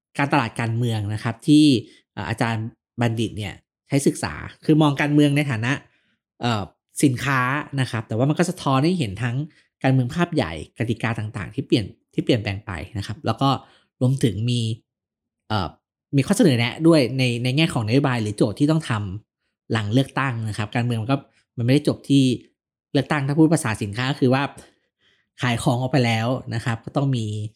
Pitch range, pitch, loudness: 115-145 Hz, 125 Hz, -22 LUFS